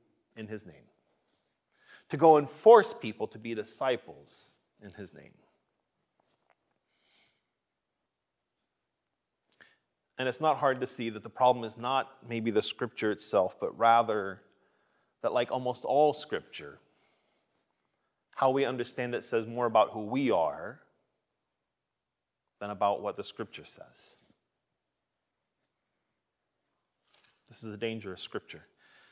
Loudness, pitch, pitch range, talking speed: -29 LUFS, 115 Hz, 110-135 Hz, 115 wpm